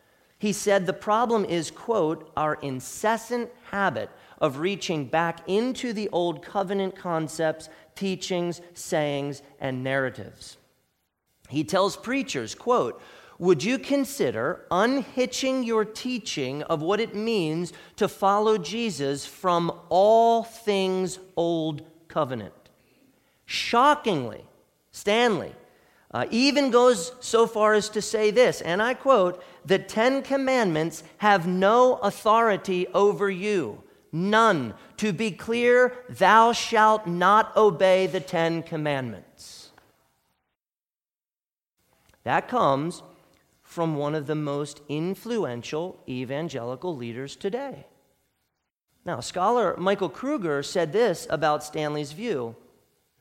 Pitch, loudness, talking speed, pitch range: 190 Hz, -24 LUFS, 110 wpm, 155-220 Hz